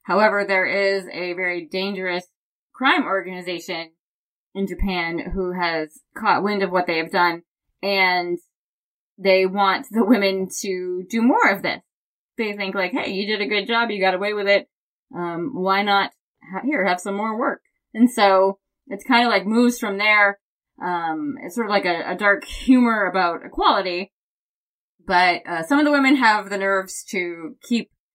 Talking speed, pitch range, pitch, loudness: 175 wpm, 180-210 Hz, 195 Hz, -20 LUFS